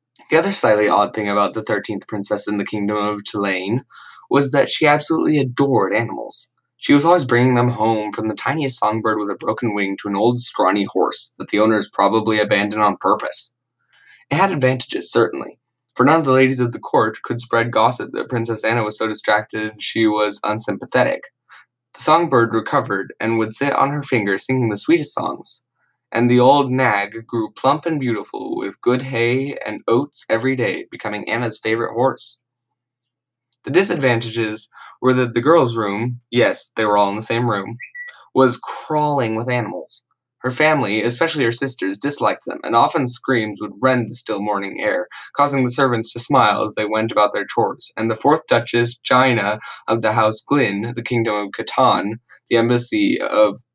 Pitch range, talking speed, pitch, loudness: 105-130 Hz, 185 wpm, 115 Hz, -18 LUFS